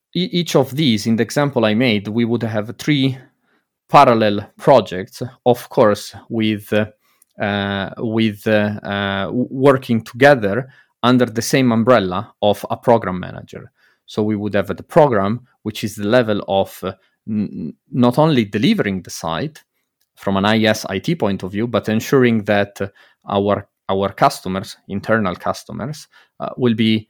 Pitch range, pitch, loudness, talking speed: 100-125 Hz, 110 Hz, -17 LUFS, 155 wpm